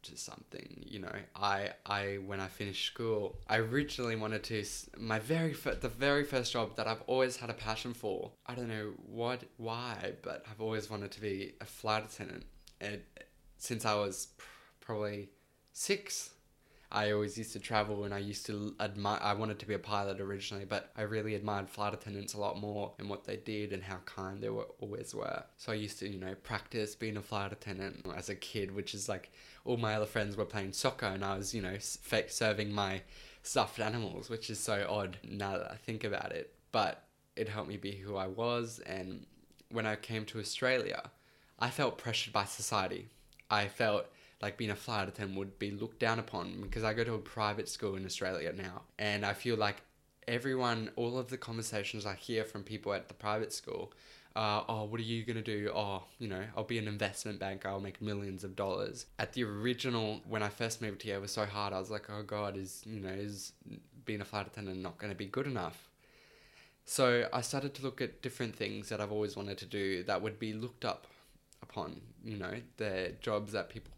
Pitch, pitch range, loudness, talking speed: 105 Hz, 100-115 Hz, -38 LUFS, 215 wpm